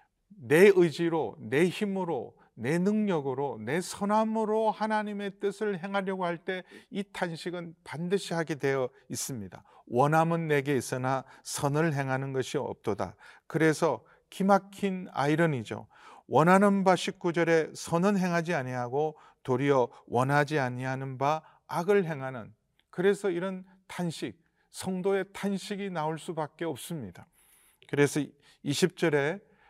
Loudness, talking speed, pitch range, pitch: -29 LUFS, 265 characters per minute, 145-195 Hz, 170 Hz